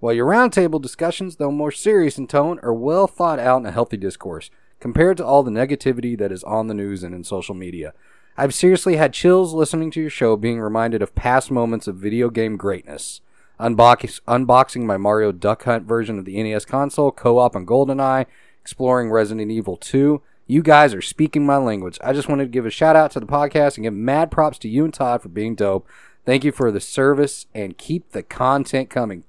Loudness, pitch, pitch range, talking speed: -18 LUFS, 130 Hz, 110-145 Hz, 215 wpm